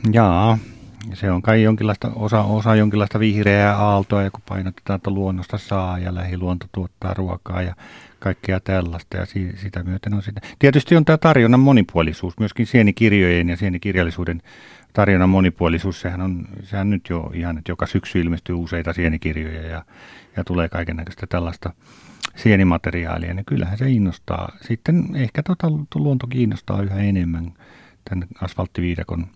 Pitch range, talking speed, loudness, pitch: 90-110 Hz, 145 wpm, -20 LUFS, 95 Hz